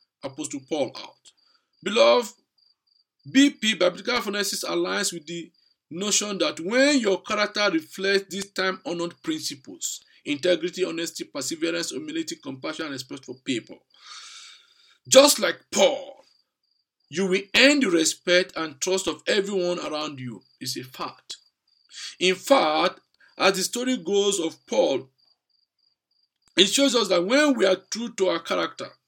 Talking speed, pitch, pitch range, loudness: 135 wpm, 195 Hz, 180-270 Hz, -23 LUFS